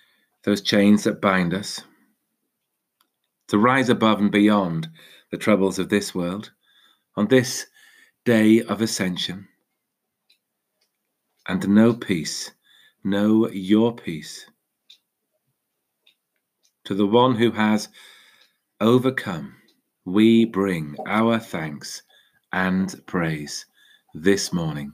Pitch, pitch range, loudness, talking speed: 105 Hz, 95-115 Hz, -21 LUFS, 100 wpm